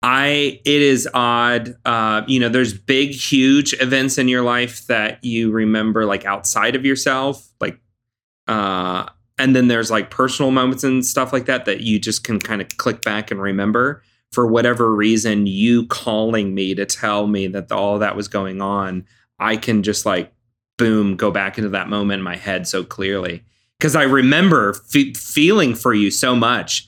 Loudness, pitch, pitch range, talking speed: -17 LUFS, 115 Hz, 105-130 Hz, 185 wpm